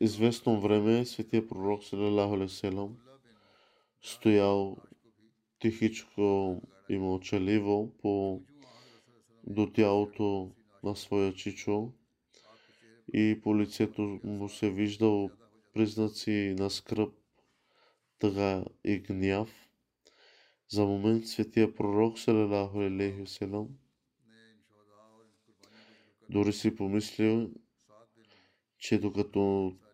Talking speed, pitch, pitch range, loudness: 75 wpm, 105 Hz, 100-110 Hz, -31 LUFS